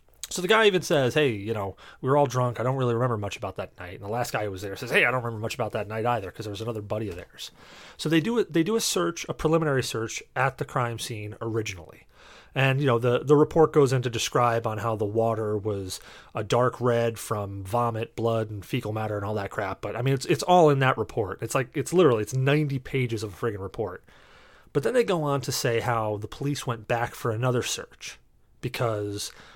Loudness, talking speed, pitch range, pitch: -26 LUFS, 250 wpm, 110-135 Hz, 120 Hz